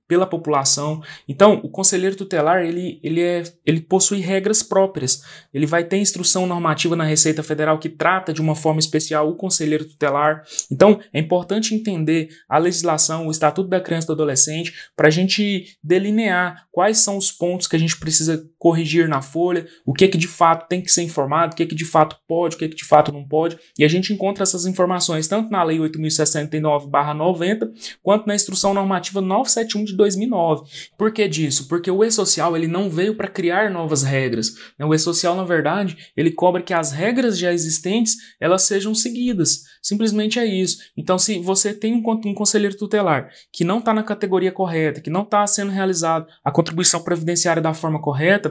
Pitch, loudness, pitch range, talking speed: 175 Hz, -18 LUFS, 155-195 Hz, 190 wpm